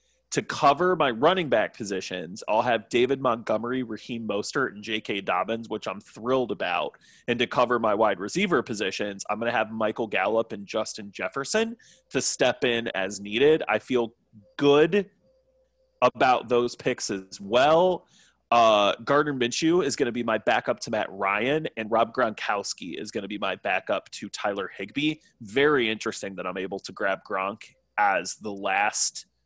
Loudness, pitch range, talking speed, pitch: -25 LUFS, 110-150 Hz, 170 wpm, 120 Hz